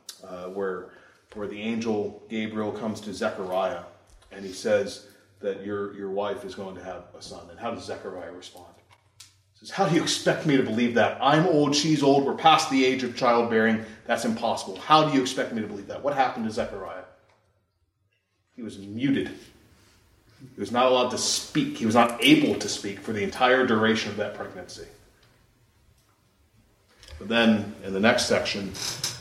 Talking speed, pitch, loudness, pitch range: 185 wpm, 110 Hz, -24 LUFS, 95-120 Hz